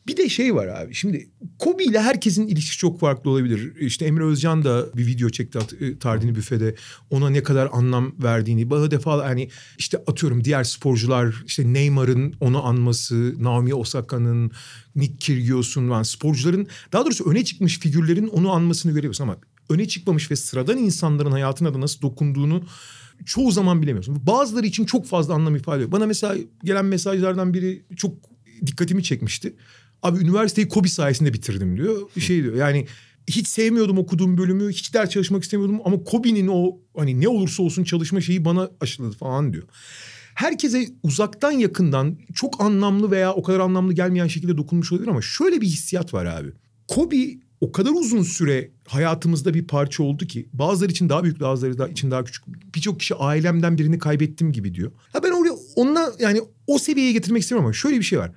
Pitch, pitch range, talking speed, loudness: 160 Hz, 130-190 Hz, 175 wpm, -21 LUFS